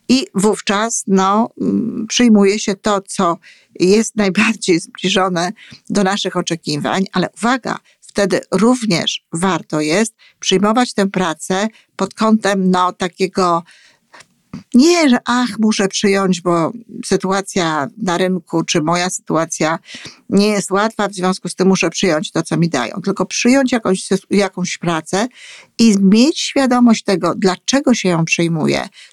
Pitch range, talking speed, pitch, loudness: 180-220 Hz, 130 wpm, 195 Hz, -16 LUFS